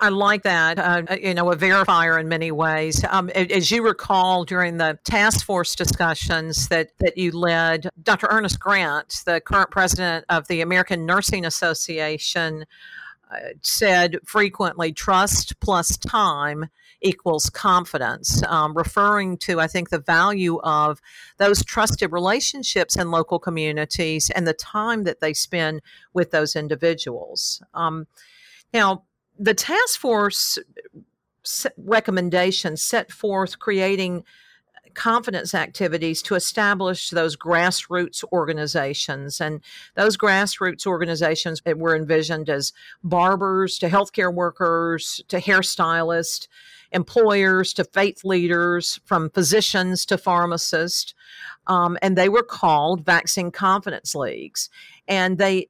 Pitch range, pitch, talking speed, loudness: 165-195 Hz, 180 Hz, 120 wpm, -20 LUFS